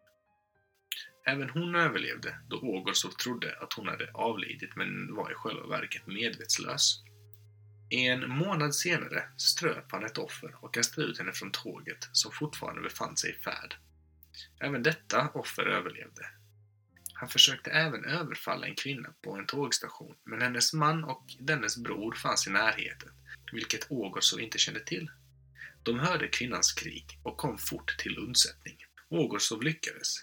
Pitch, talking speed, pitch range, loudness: 125 Hz, 145 wpm, 105-155 Hz, -31 LUFS